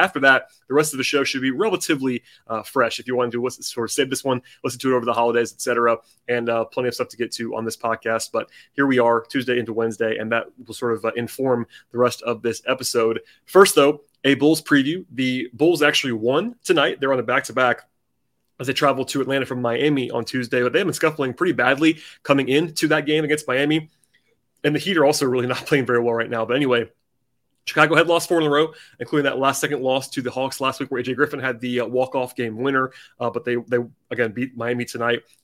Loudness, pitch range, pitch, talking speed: -21 LUFS, 120-145 Hz, 130 Hz, 245 wpm